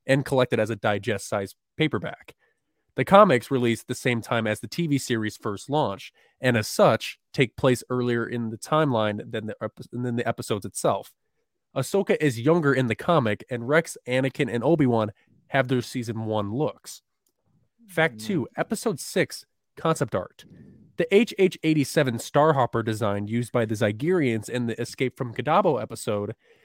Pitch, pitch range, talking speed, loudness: 125 Hz, 115-155 Hz, 160 wpm, -25 LUFS